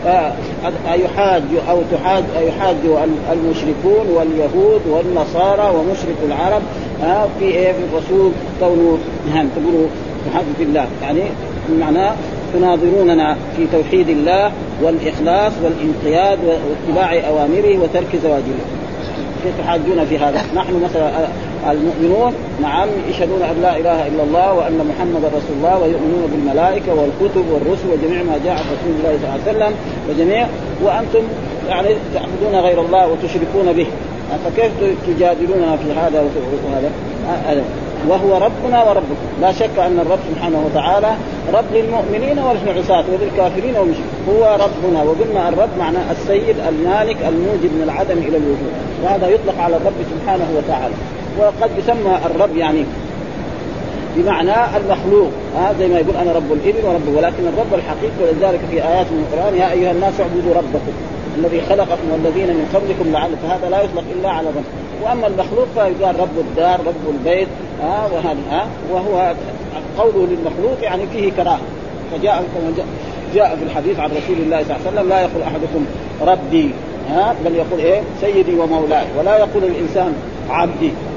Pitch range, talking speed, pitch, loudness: 160-195 Hz, 140 wpm, 175 Hz, -16 LUFS